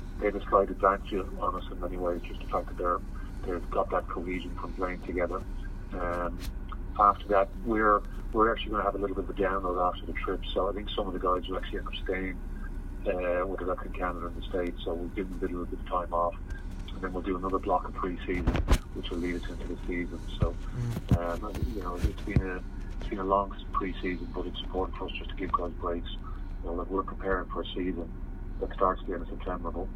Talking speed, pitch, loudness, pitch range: 245 wpm, 90 Hz, -32 LUFS, 90-95 Hz